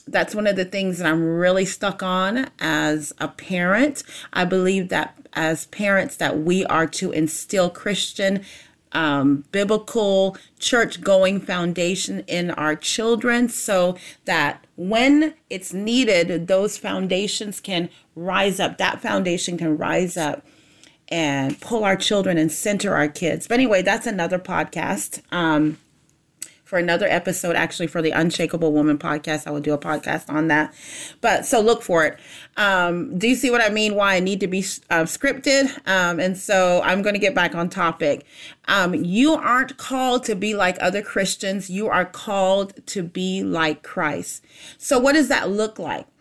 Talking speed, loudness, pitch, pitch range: 165 wpm, -21 LUFS, 185 Hz, 170-205 Hz